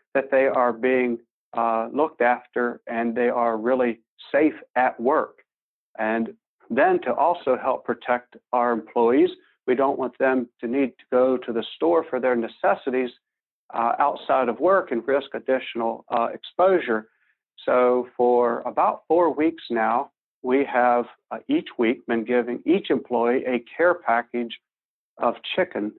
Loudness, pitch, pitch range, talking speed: -23 LUFS, 125 Hz, 120-135 Hz, 150 wpm